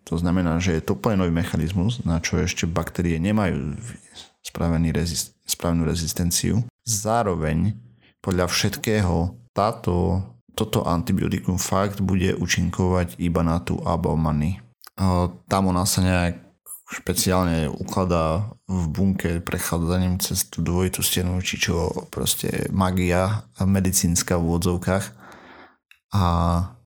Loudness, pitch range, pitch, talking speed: -23 LUFS, 85-95 Hz, 90 Hz, 110 wpm